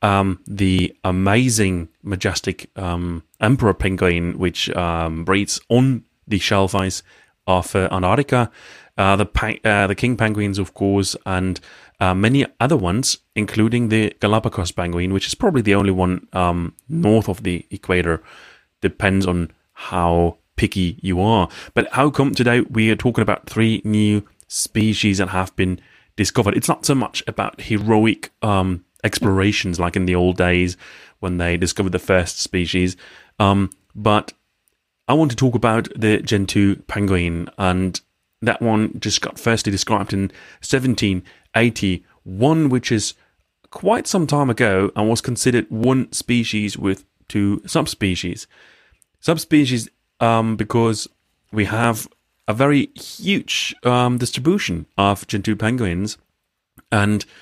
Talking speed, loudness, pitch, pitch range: 135 wpm, -19 LUFS, 100 Hz, 90-110 Hz